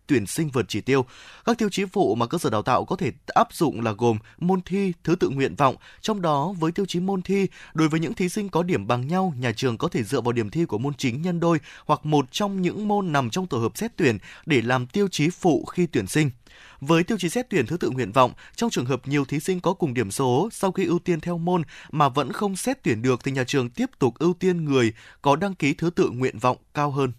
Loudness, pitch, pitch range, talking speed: -24 LUFS, 160 Hz, 130-185 Hz, 270 wpm